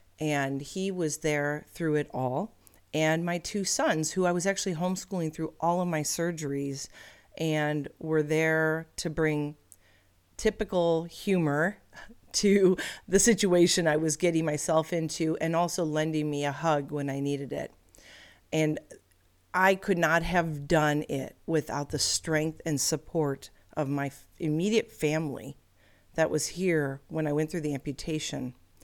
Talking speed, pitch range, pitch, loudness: 150 wpm, 145-170 Hz, 155 Hz, -28 LUFS